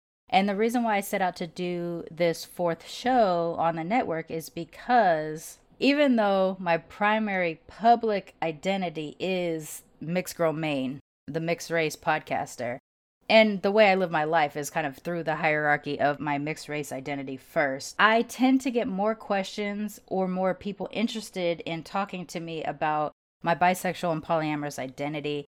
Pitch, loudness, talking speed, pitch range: 170 Hz, -27 LUFS, 165 wpm, 155-200 Hz